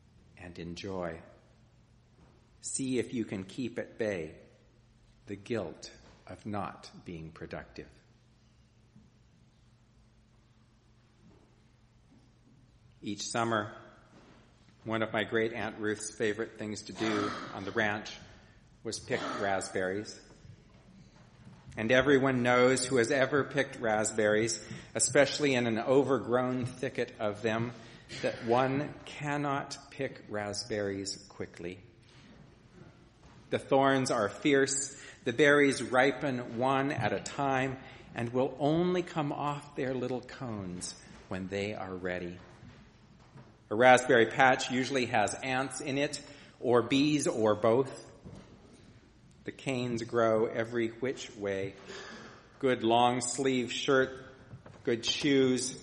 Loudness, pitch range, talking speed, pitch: -31 LUFS, 110-130 Hz, 110 wpm, 120 Hz